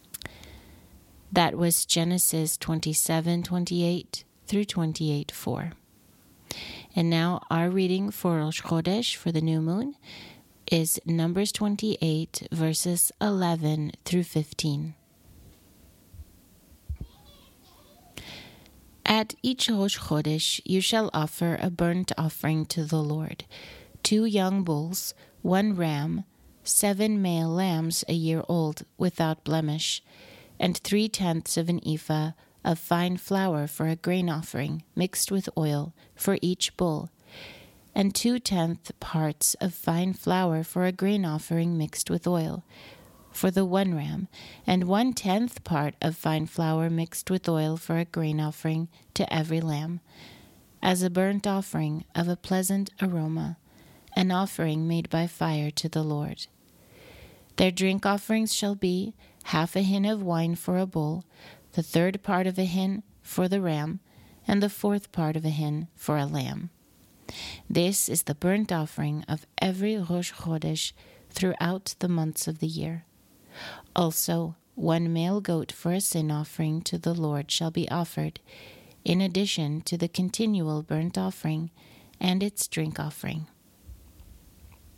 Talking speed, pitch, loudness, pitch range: 135 wpm, 170 Hz, -27 LUFS, 155-185 Hz